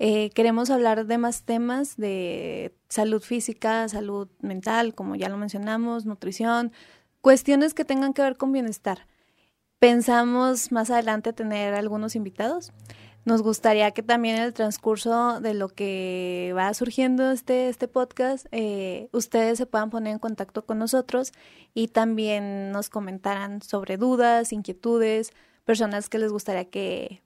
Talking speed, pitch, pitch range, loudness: 145 wpm, 225 Hz, 205-240 Hz, -25 LUFS